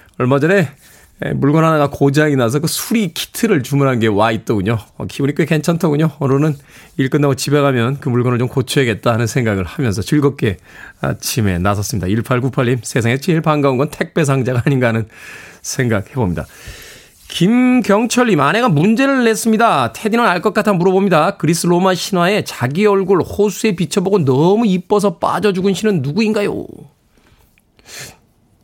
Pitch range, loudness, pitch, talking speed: 130-200 Hz, -15 LUFS, 150 Hz, 350 characters per minute